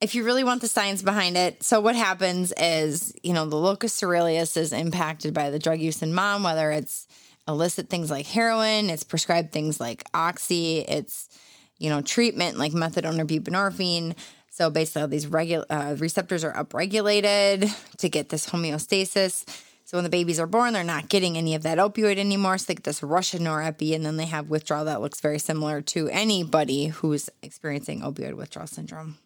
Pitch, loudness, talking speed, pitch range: 165 Hz, -25 LUFS, 195 wpm, 155-195 Hz